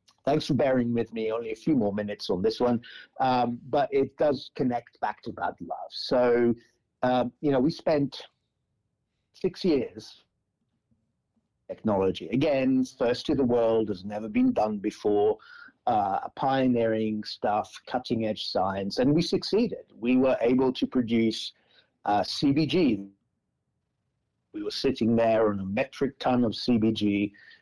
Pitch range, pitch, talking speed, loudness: 110-145 Hz, 125 Hz, 145 wpm, -27 LUFS